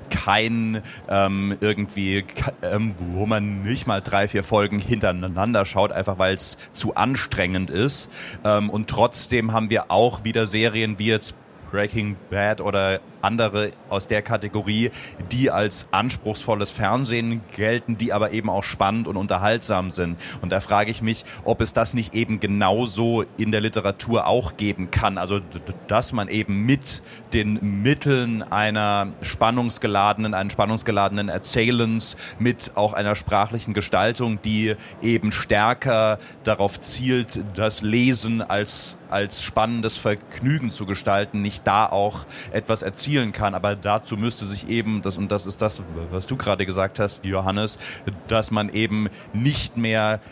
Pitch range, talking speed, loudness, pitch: 100-115 Hz, 145 wpm, -23 LUFS, 105 Hz